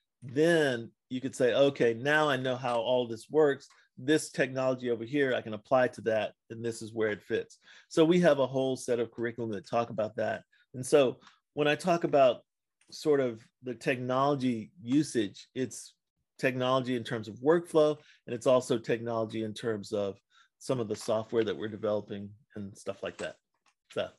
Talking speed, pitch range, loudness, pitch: 185 wpm, 115-140 Hz, -30 LUFS, 125 Hz